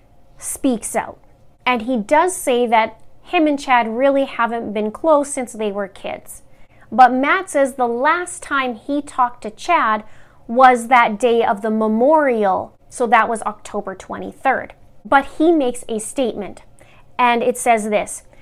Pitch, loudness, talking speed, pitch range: 245 Hz, -17 LUFS, 155 wpm, 220-275 Hz